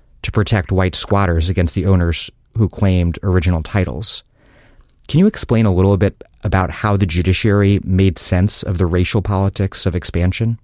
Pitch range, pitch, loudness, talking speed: 90-100 Hz, 95 Hz, -16 LUFS, 165 wpm